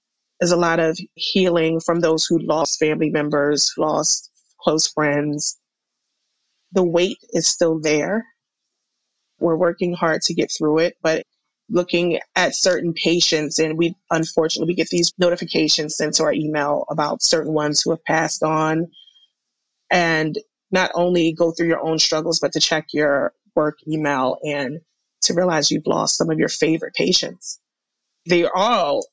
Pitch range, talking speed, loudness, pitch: 155-175 Hz, 155 wpm, -19 LUFS, 160 Hz